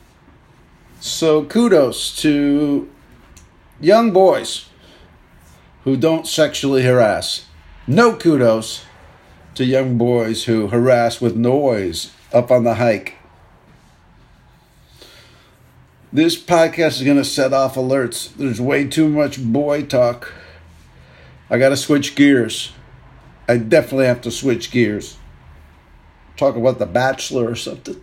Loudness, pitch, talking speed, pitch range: -16 LUFS, 125 Hz, 115 wpm, 110-145 Hz